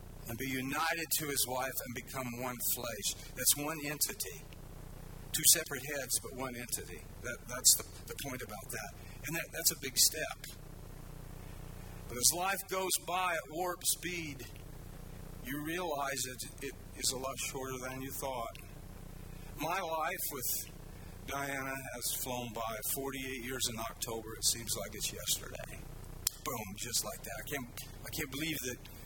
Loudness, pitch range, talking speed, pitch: -34 LUFS, 120-145 Hz, 160 wpm, 130 Hz